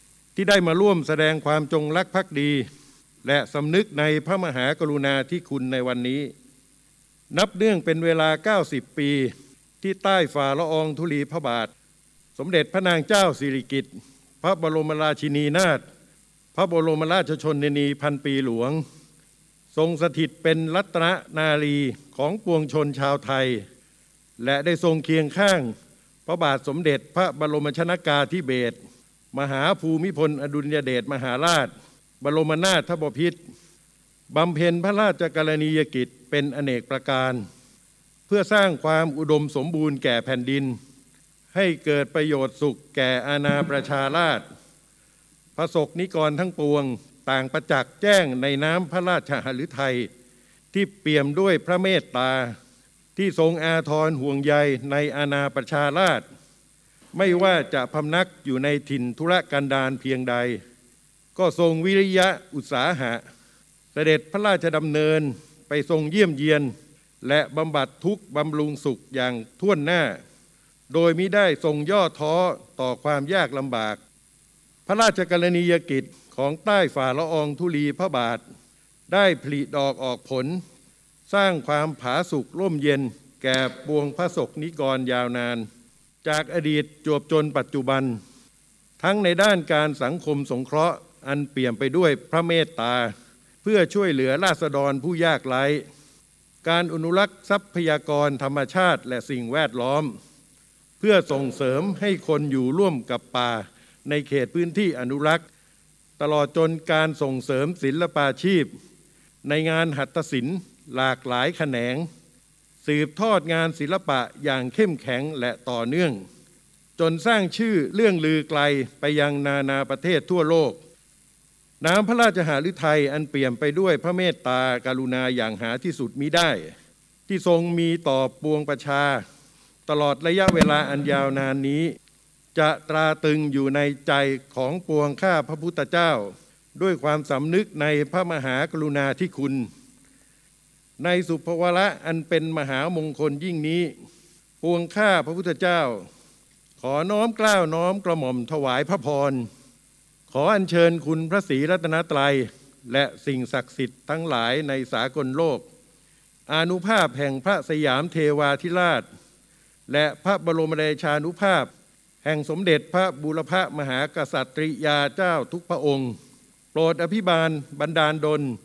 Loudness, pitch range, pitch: -23 LUFS, 140-170 Hz, 150 Hz